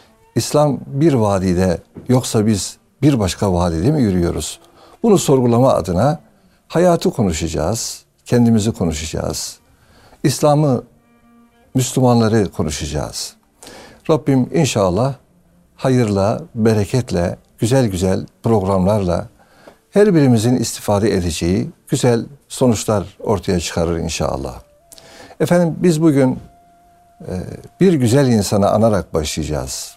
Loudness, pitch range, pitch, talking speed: -17 LUFS, 95-140 Hz, 115 Hz, 90 wpm